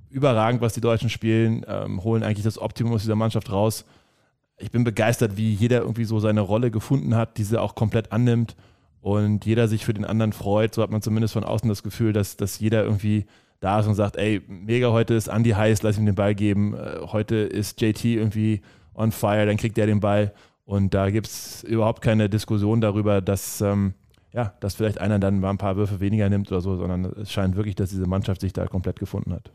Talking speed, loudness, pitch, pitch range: 220 wpm, -23 LUFS, 105 Hz, 100-110 Hz